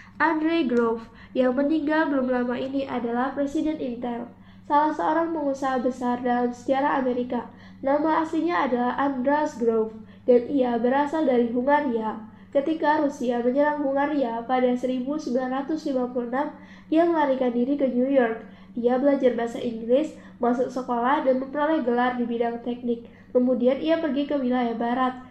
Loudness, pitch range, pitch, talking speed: -24 LUFS, 245-290 Hz, 255 Hz, 135 wpm